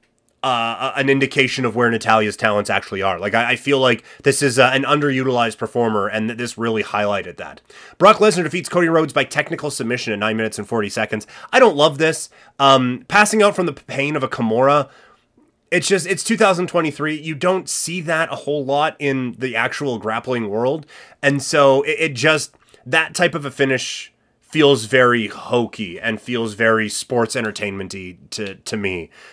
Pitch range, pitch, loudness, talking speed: 115-155 Hz, 130 Hz, -18 LUFS, 185 wpm